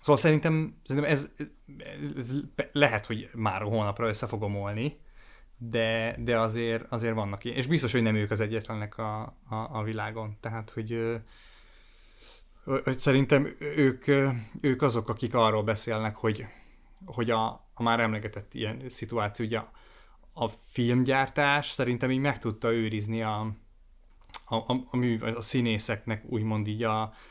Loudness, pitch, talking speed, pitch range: -29 LUFS, 115 Hz, 145 wpm, 110-130 Hz